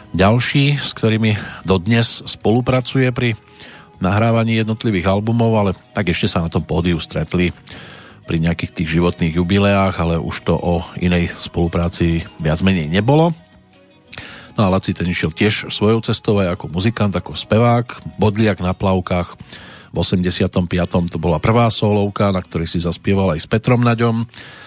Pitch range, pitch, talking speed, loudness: 85-115 Hz, 95 Hz, 150 wpm, -17 LUFS